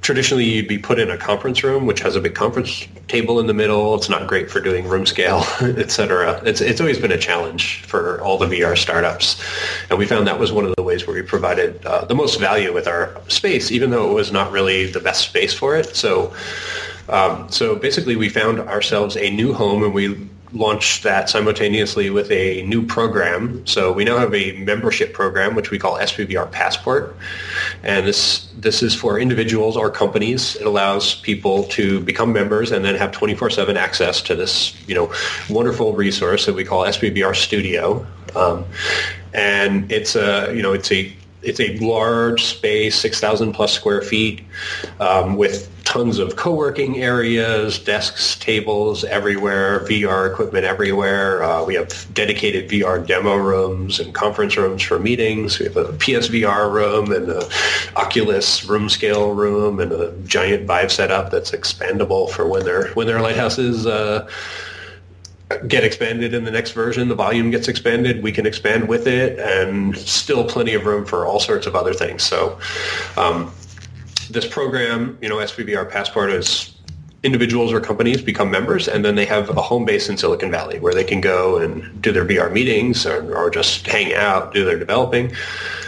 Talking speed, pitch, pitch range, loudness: 185 wpm, 110 Hz, 100-140 Hz, -18 LUFS